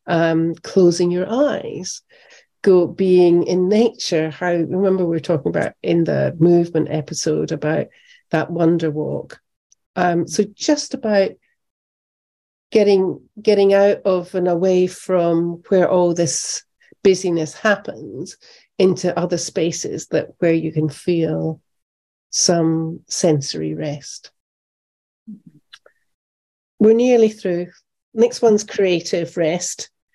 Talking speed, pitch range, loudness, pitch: 110 wpm, 165-200 Hz, -18 LUFS, 175 Hz